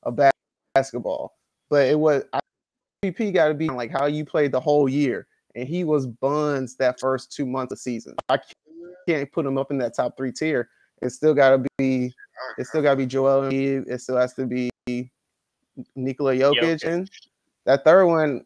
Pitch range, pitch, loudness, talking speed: 130-155 Hz, 135 Hz, -23 LUFS, 200 wpm